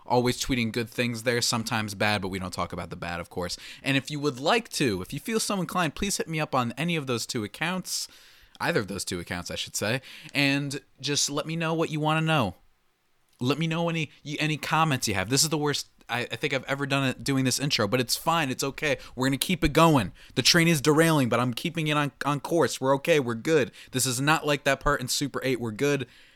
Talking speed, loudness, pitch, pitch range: 255 wpm, -26 LUFS, 135 Hz, 120-155 Hz